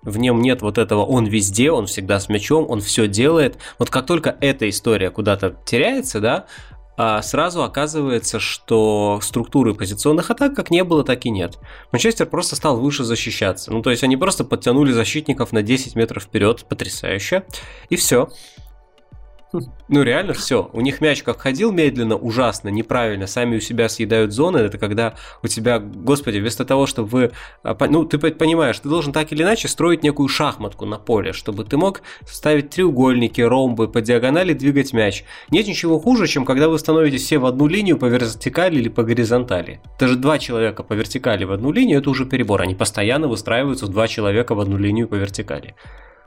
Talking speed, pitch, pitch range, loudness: 180 wpm, 120 Hz, 110-145 Hz, -18 LUFS